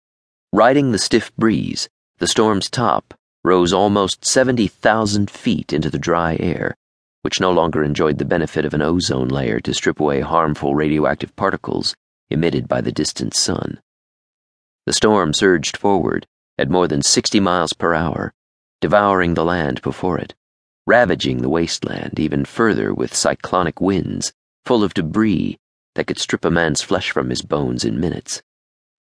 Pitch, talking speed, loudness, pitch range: 75 Hz, 150 wpm, -18 LUFS, 70-95 Hz